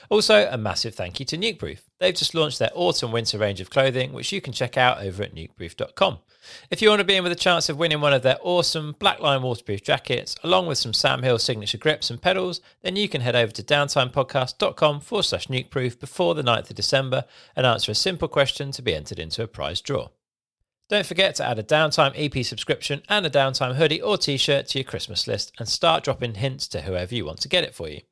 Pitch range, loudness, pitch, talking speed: 115-160 Hz, -22 LUFS, 135 Hz, 235 wpm